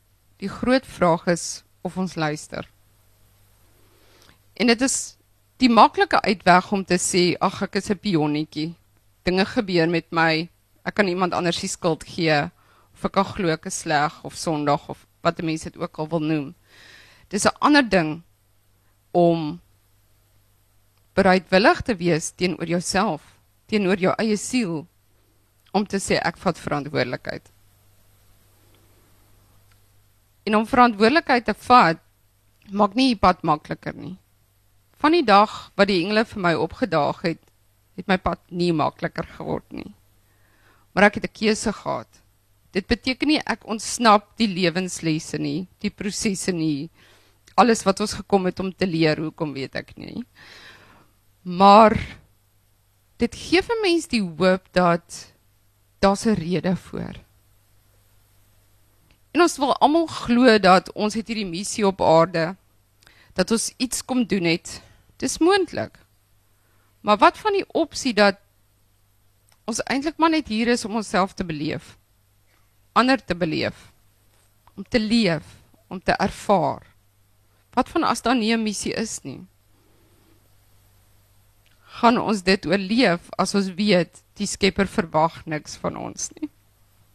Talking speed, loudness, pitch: 140 wpm, -21 LUFS, 165 Hz